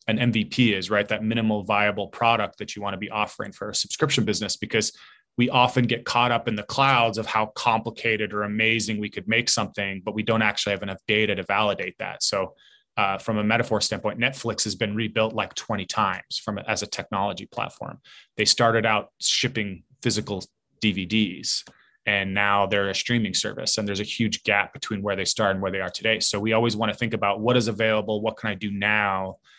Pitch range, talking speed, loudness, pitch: 100-115 Hz, 210 wpm, -24 LUFS, 110 Hz